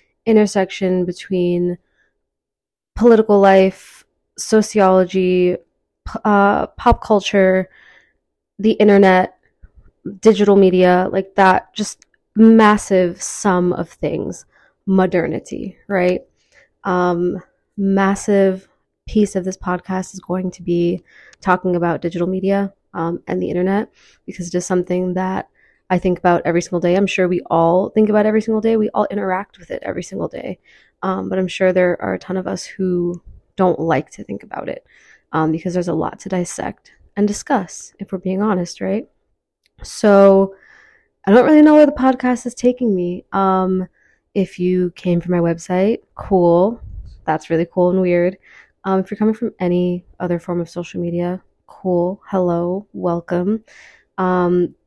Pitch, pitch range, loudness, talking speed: 185 Hz, 180-205 Hz, -17 LUFS, 150 wpm